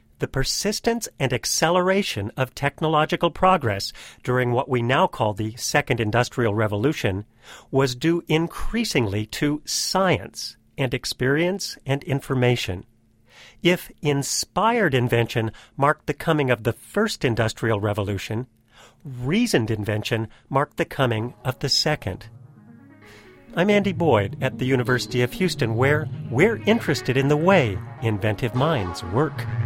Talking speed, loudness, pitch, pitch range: 125 wpm, -22 LUFS, 130 Hz, 115-155 Hz